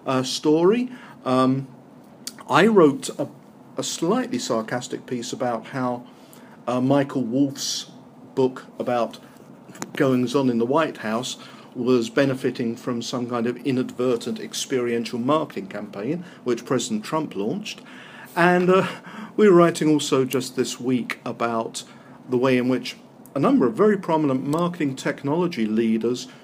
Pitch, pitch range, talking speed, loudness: 130 Hz, 125-155 Hz, 135 wpm, -23 LUFS